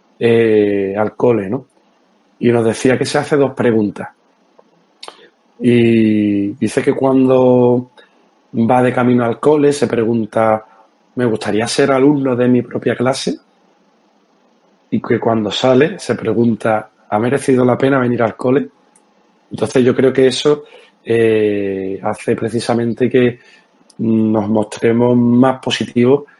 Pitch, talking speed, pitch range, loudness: 120 Hz, 130 wpm, 110-130 Hz, -14 LUFS